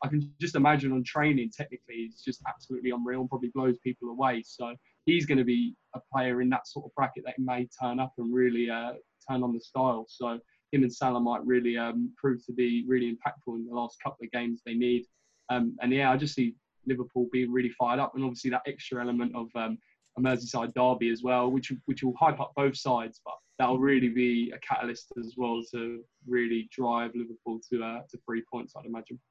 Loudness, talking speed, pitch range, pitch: -30 LUFS, 225 wpm, 120-130 Hz, 125 Hz